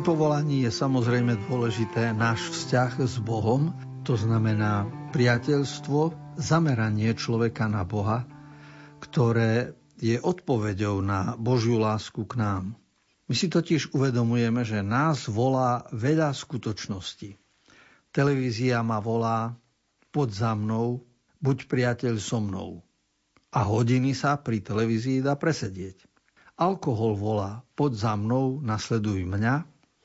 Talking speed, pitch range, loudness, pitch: 110 wpm, 110-140 Hz, -26 LUFS, 120 Hz